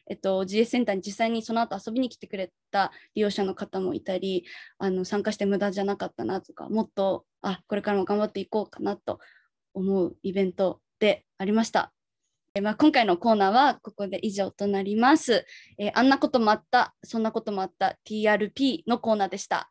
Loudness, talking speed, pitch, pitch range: -26 LUFS, 400 characters per minute, 205 Hz, 195-225 Hz